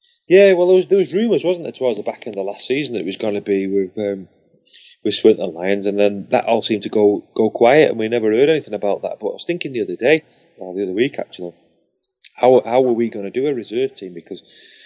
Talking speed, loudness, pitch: 280 wpm, -17 LUFS, 115 Hz